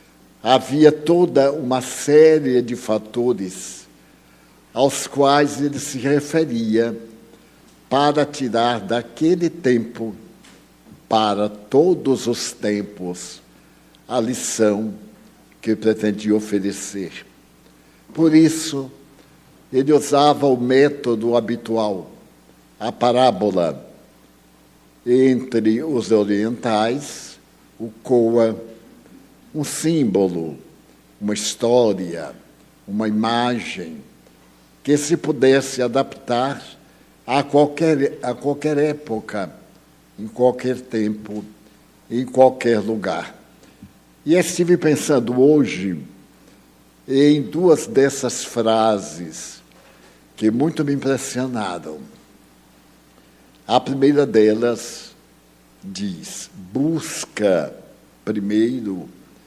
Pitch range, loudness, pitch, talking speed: 100-140 Hz, -19 LUFS, 120 Hz, 80 wpm